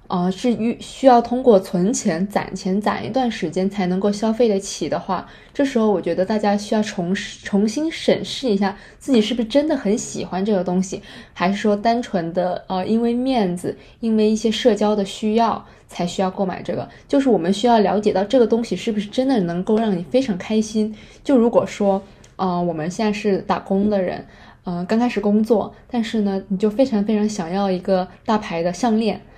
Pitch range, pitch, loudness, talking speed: 190-230 Hz, 210 Hz, -20 LUFS, 305 characters per minute